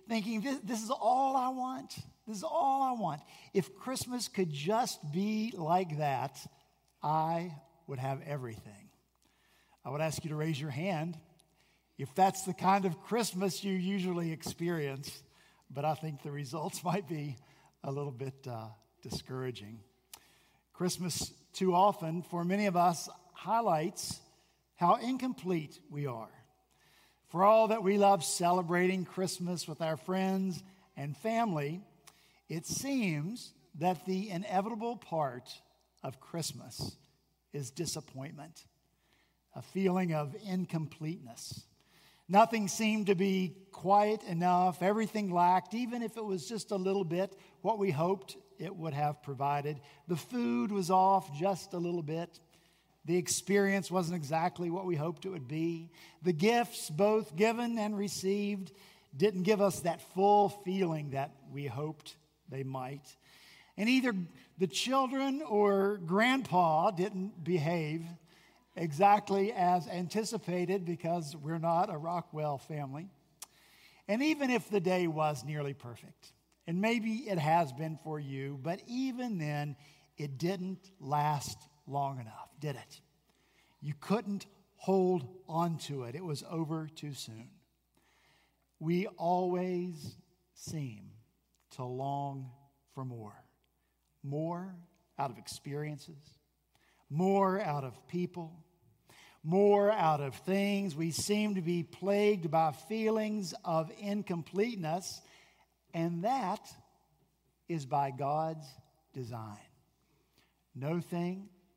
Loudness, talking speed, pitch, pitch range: -33 LUFS, 125 wpm, 175 Hz, 150-195 Hz